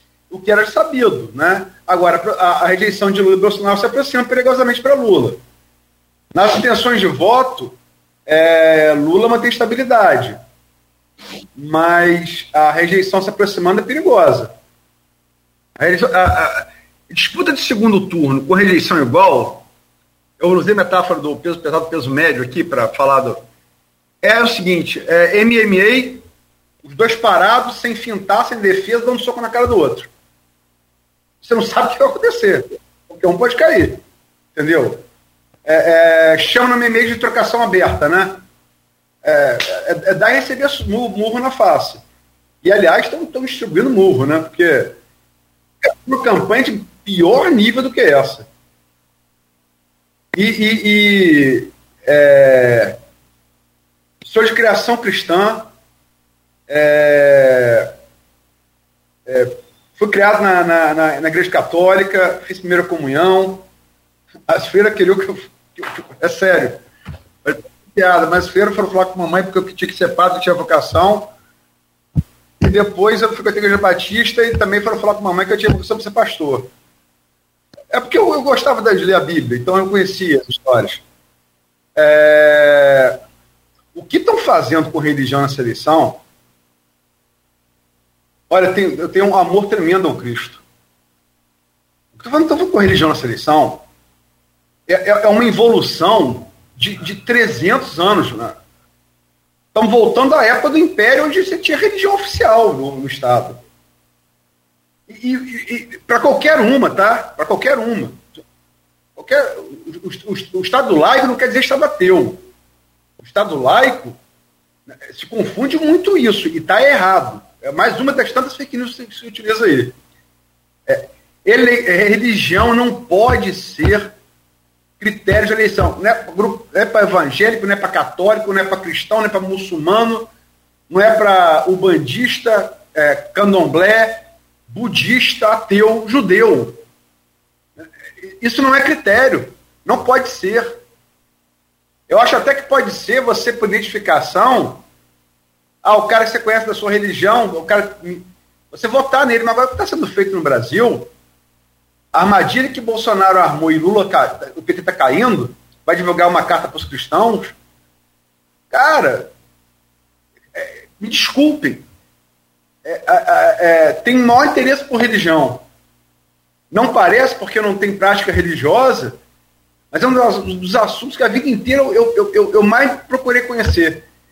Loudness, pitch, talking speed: -13 LUFS, 185 Hz, 145 wpm